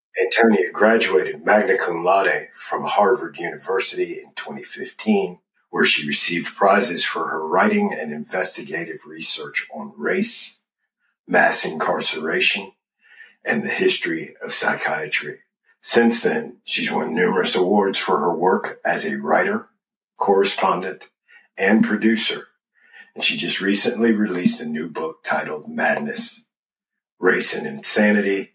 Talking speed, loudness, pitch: 120 wpm, -19 LUFS, 205 Hz